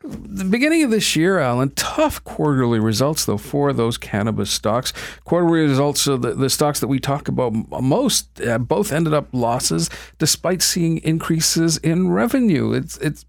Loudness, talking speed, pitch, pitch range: -19 LUFS, 165 wpm, 150 Hz, 125-170 Hz